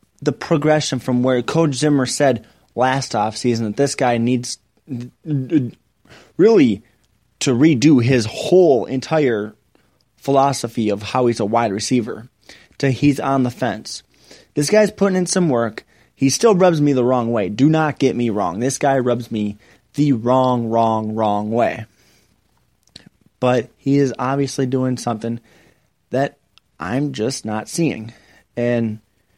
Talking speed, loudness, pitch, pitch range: 145 wpm, -18 LUFS, 125 Hz, 115-140 Hz